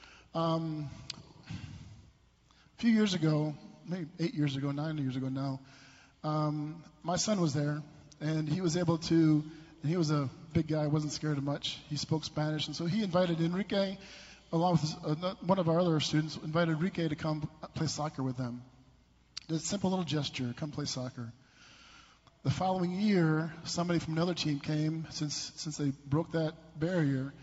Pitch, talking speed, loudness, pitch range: 155 Hz, 175 wpm, -33 LUFS, 145-170 Hz